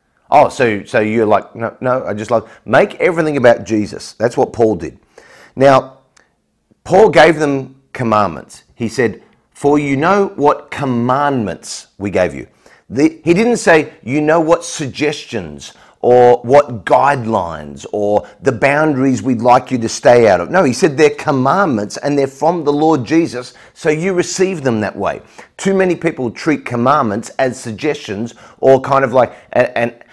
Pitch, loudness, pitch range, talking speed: 135 Hz, -14 LUFS, 115-155 Hz, 165 wpm